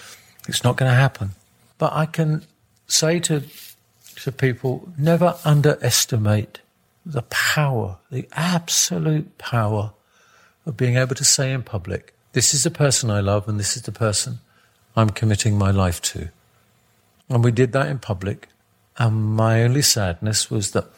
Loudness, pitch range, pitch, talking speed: -20 LUFS, 105-145 Hz, 120 Hz, 150 wpm